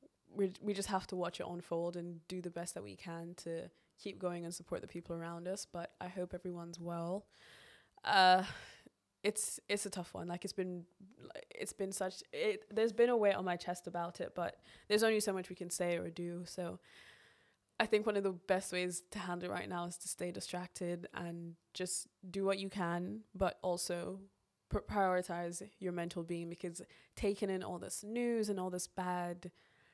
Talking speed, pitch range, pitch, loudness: 200 wpm, 175-195 Hz, 180 Hz, -39 LUFS